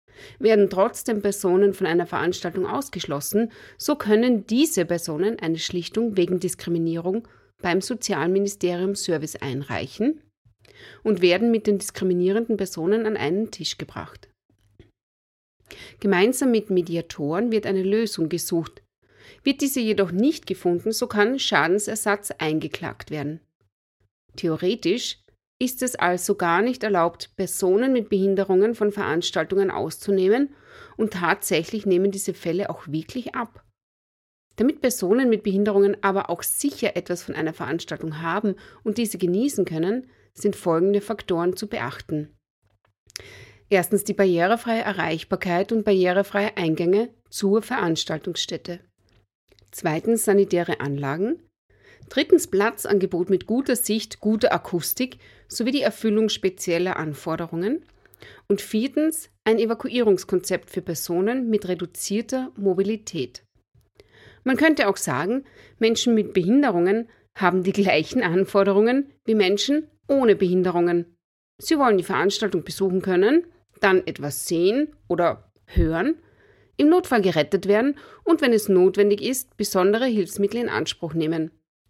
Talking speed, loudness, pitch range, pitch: 120 wpm, -23 LUFS, 170-220 Hz, 195 Hz